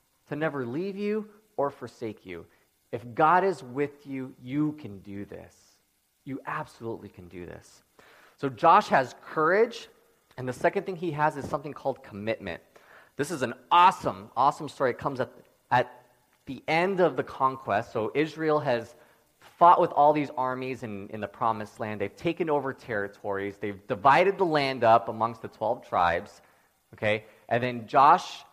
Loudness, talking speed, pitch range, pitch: -26 LUFS, 170 wpm, 105-150 Hz, 130 Hz